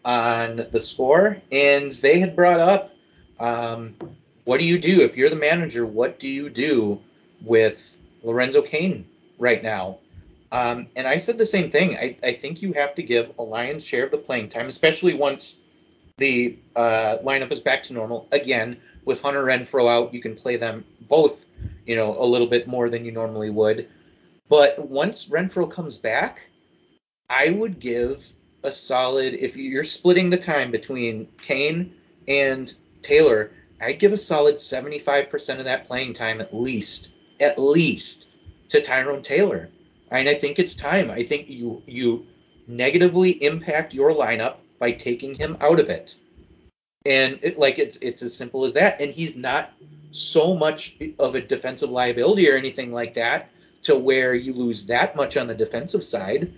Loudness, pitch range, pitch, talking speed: -21 LUFS, 120-160 Hz, 135 Hz, 175 wpm